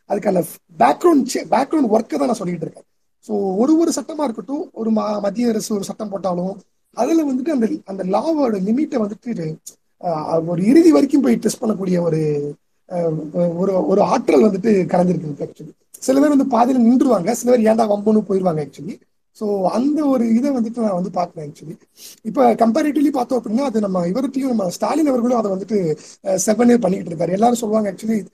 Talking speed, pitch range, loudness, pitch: 155 wpm, 185-250 Hz, -18 LUFS, 220 Hz